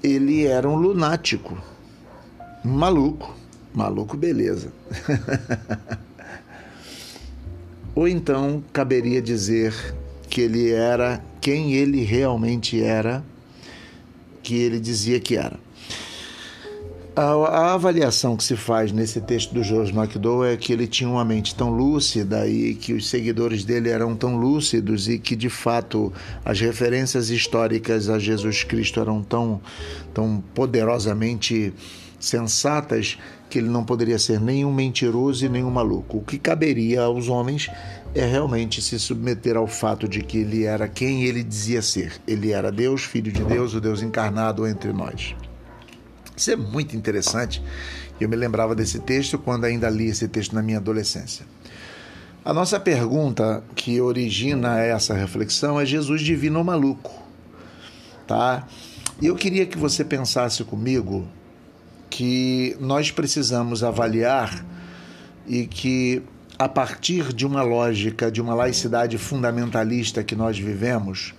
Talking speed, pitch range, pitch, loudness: 135 wpm, 110-125 Hz, 115 Hz, -22 LUFS